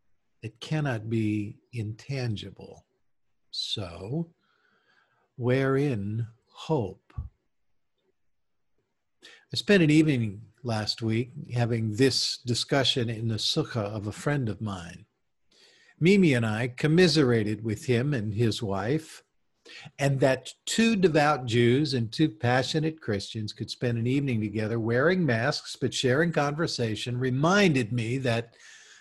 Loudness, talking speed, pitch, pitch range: -26 LUFS, 115 wpm, 125 Hz, 110-150 Hz